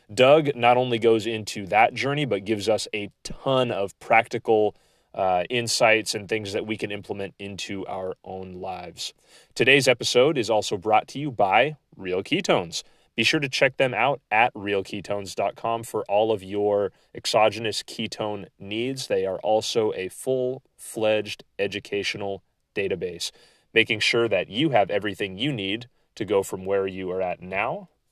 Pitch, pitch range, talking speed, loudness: 110 Hz, 100-120 Hz, 160 wpm, -24 LUFS